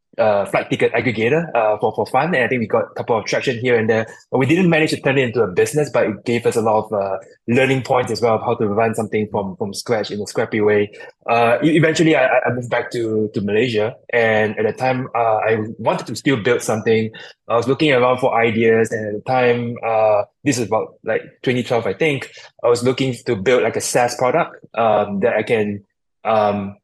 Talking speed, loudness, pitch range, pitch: 235 wpm, -18 LUFS, 110-130 Hz, 115 Hz